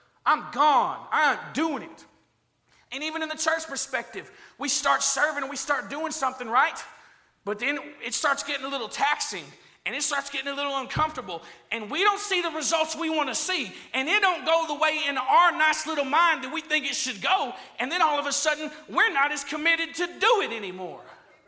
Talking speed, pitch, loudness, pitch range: 215 wpm, 300 Hz, -25 LUFS, 275-320 Hz